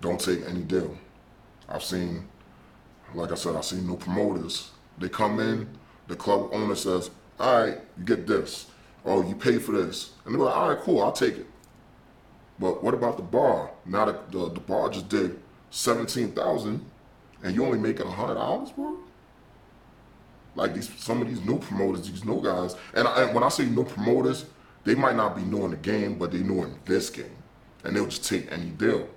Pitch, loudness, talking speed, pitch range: 90 Hz, -27 LUFS, 195 wpm, 85-100 Hz